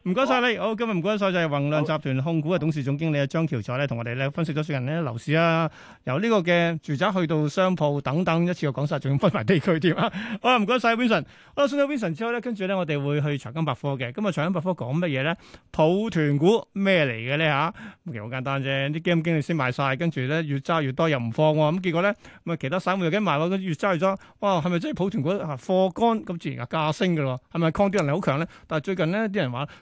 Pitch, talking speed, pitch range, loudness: 165 Hz, 405 characters per minute, 145-190 Hz, -24 LUFS